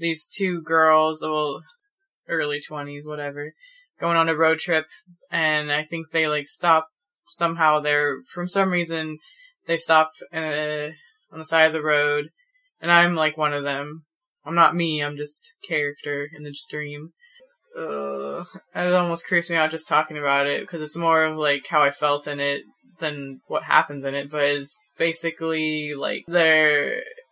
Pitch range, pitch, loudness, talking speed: 145-170 Hz, 160 Hz, -22 LUFS, 170 wpm